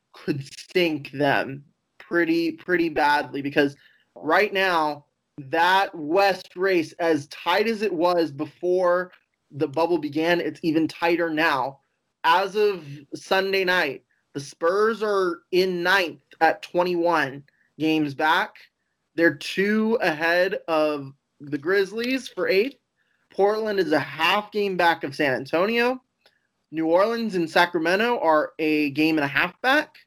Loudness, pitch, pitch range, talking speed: -23 LUFS, 170 Hz, 155-195 Hz, 130 wpm